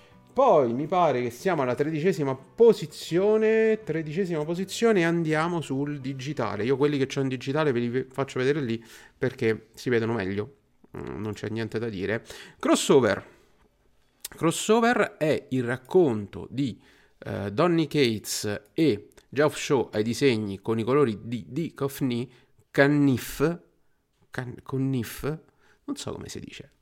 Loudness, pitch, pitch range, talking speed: -26 LUFS, 135 Hz, 115-155 Hz, 135 wpm